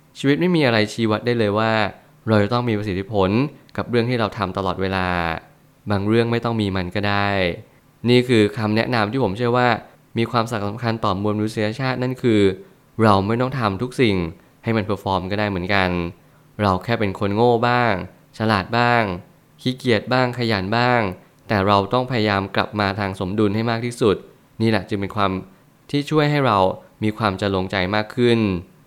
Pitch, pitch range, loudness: 110 Hz, 100-120 Hz, -20 LUFS